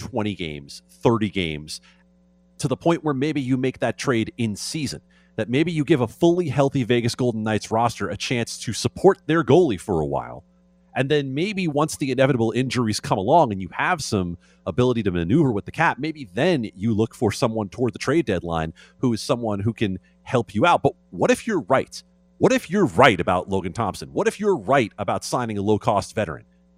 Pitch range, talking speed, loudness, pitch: 90-135 Hz, 210 wpm, -22 LUFS, 110 Hz